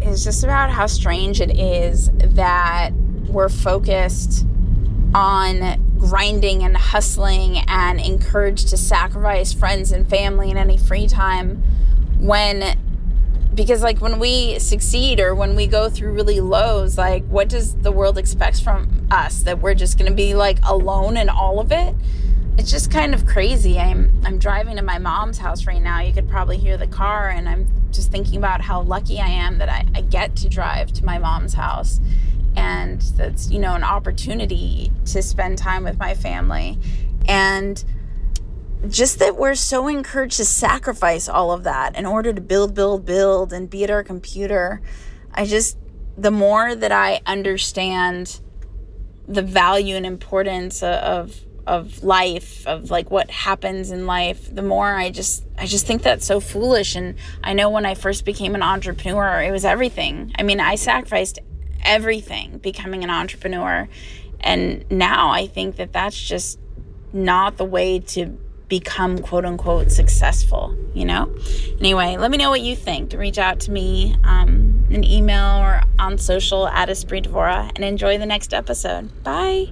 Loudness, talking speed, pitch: -19 LUFS, 170 wpm, 190 Hz